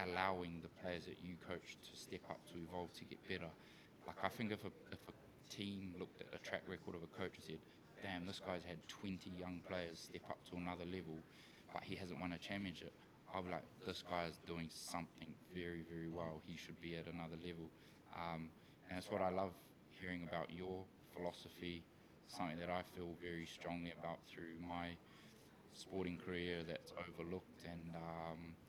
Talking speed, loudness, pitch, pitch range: 190 wpm, -50 LUFS, 85 Hz, 85-90 Hz